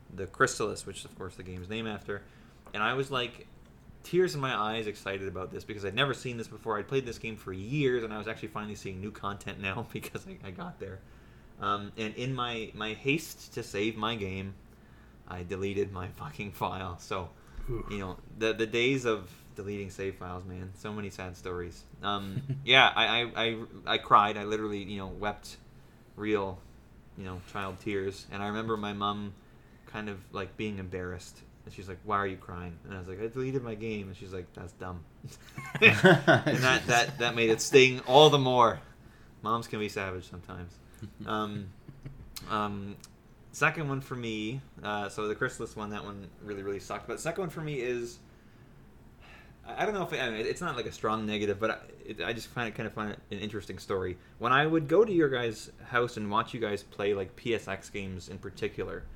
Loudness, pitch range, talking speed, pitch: -30 LUFS, 100-120 Hz, 205 wpm, 105 Hz